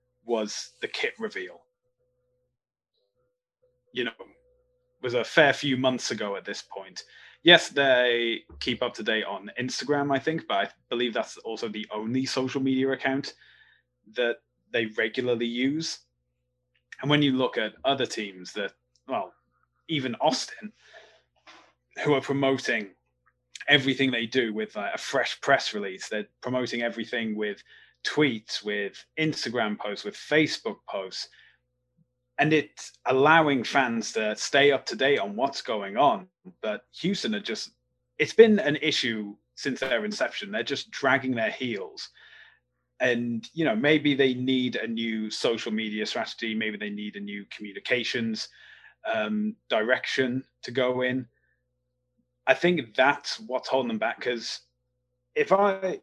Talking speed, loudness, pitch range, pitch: 145 wpm, -26 LUFS, 115-155 Hz, 125 Hz